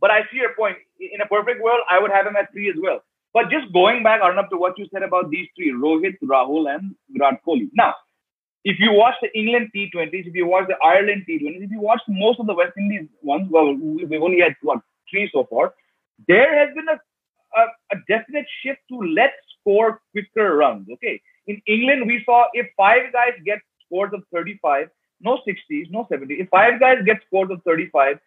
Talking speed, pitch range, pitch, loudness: 210 wpm, 185-240 Hz, 210 Hz, -19 LUFS